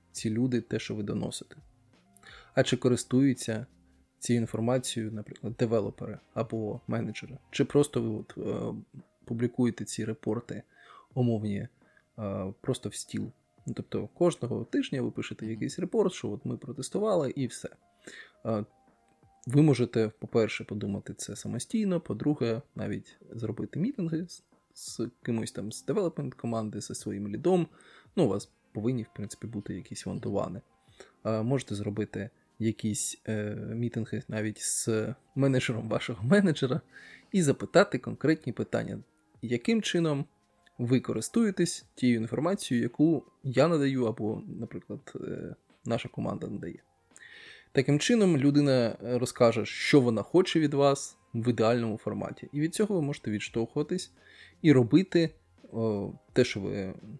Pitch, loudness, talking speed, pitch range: 120 Hz, -30 LUFS, 125 wpm, 110-140 Hz